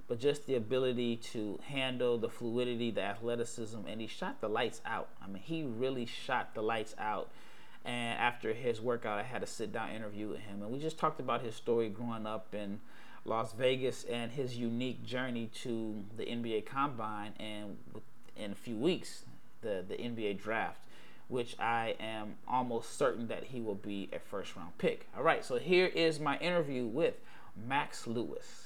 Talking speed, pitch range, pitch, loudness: 185 wpm, 110-130 Hz, 115 Hz, -37 LUFS